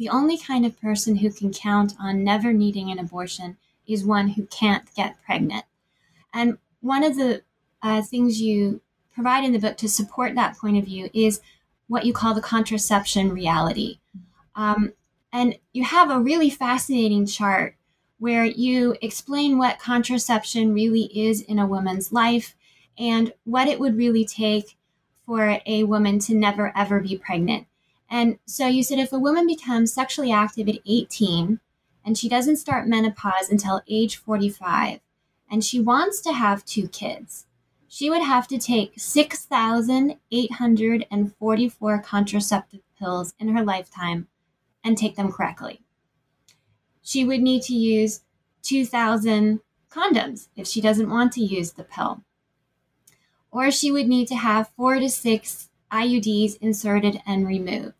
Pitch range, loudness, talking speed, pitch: 205-245 Hz, -22 LUFS, 150 wpm, 220 Hz